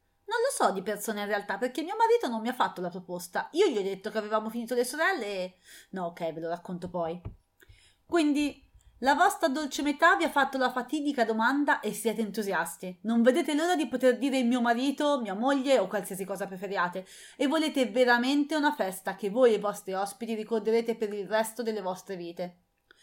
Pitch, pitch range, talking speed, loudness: 230 Hz, 195-285 Hz, 205 wpm, -28 LUFS